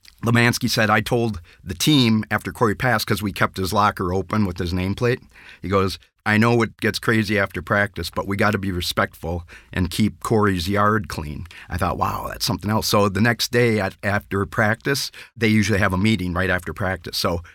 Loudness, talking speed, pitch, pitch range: -21 LUFS, 205 wpm, 105 Hz, 95-115 Hz